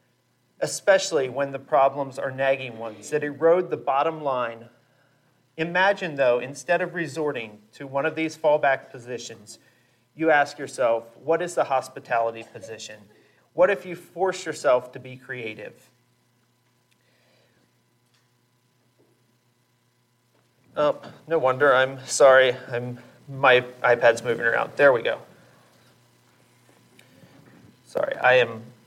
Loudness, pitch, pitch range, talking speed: -23 LUFS, 125 Hz, 120-145 Hz, 115 wpm